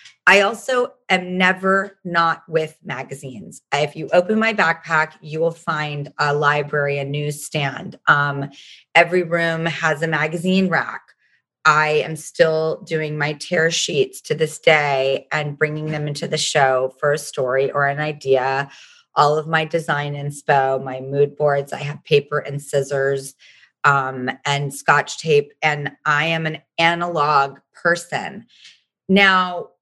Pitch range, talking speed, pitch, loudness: 145-165 Hz, 145 wpm, 150 Hz, -19 LUFS